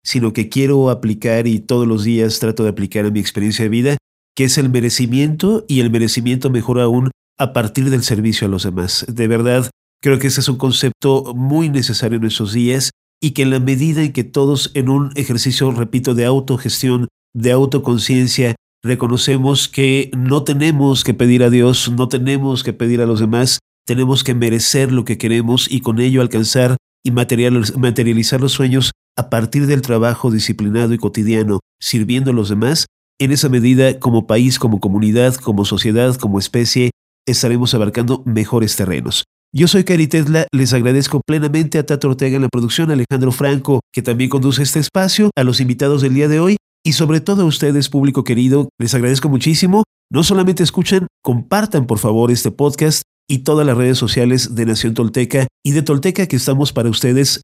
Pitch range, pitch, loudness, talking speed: 120-140 Hz, 125 Hz, -15 LUFS, 185 wpm